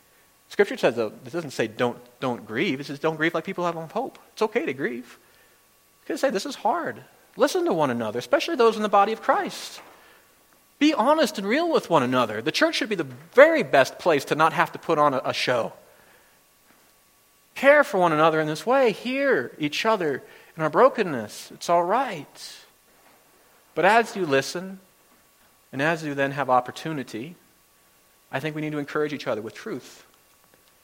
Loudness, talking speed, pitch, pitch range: -23 LUFS, 195 wpm, 170 Hz, 145-230 Hz